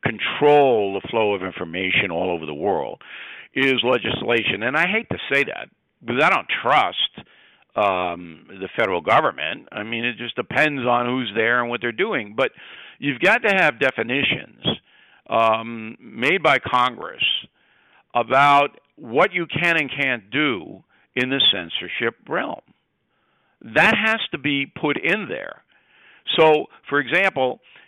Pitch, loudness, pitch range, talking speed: 130 Hz, -20 LUFS, 115-150 Hz, 145 wpm